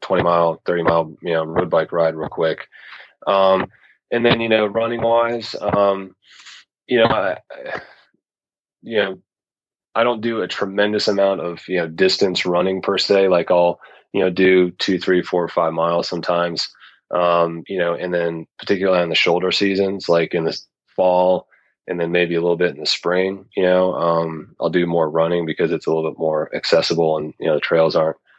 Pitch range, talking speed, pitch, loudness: 85-95 Hz, 190 wpm, 90 Hz, -18 LUFS